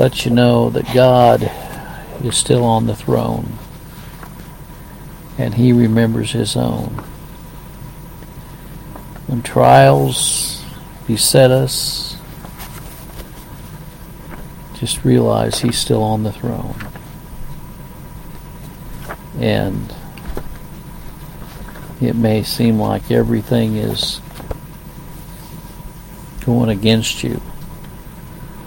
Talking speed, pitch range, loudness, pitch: 75 wpm, 110-135 Hz, -15 LUFS, 120 Hz